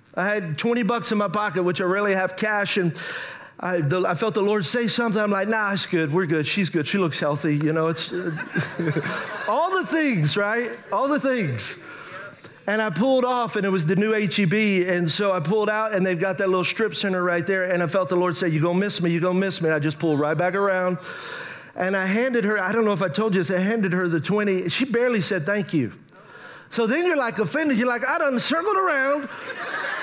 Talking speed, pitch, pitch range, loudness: 245 wpm, 195 Hz, 180-220 Hz, -22 LUFS